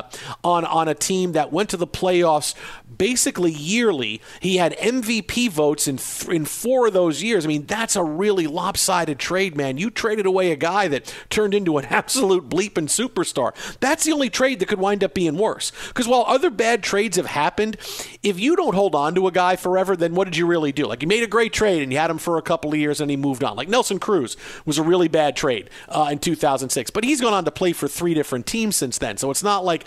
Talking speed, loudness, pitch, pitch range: 240 wpm, -20 LUFS, 180 Hz, 155-210 Hz